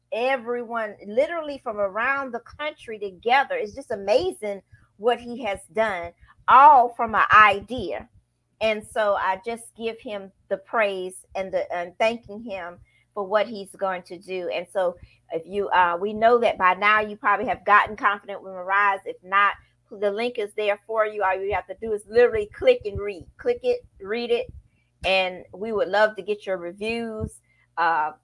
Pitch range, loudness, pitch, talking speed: 190-235 Hz, -23 LUFS, 205 Hz, 180 wpm